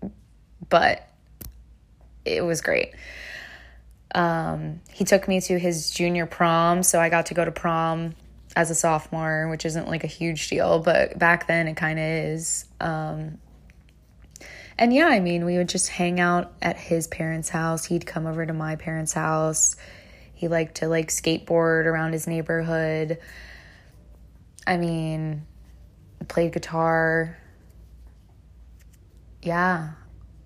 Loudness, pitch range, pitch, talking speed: -23 LUFS, 155-170 Hz, 160 Hz, 135 wpm